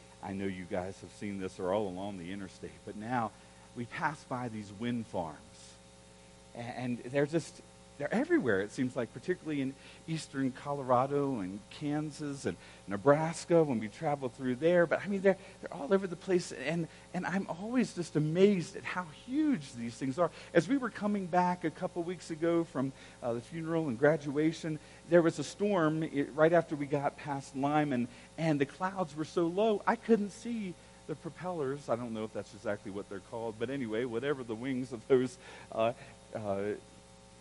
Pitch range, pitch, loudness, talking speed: 115-170 Hz, 145 Hz, -33 LUFS, 190 wpm